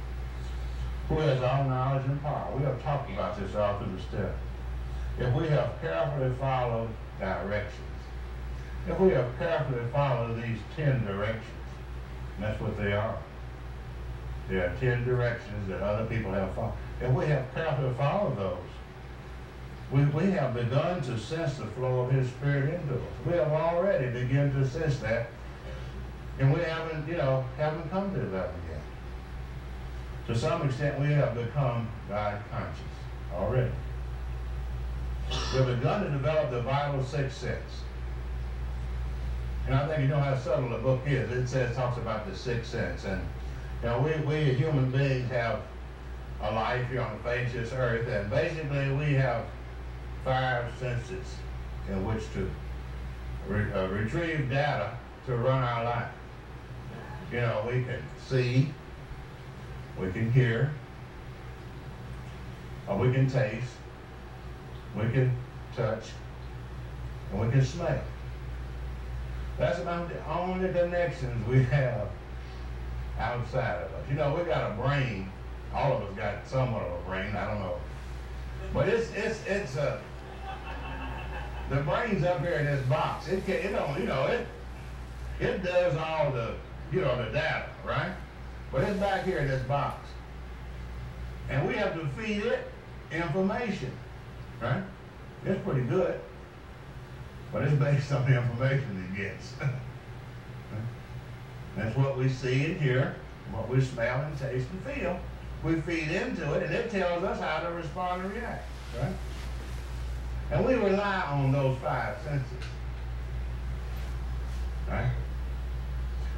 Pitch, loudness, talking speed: 115 Hz, -31 LUFS, 145 wpm